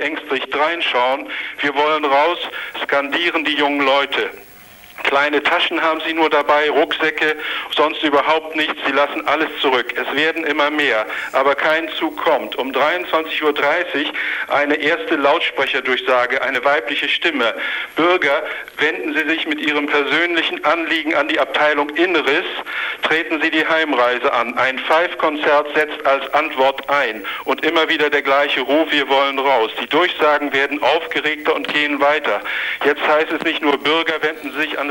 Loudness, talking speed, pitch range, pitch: -17 LUFS, 150 wpm, 140-160 Hz, 150 Hz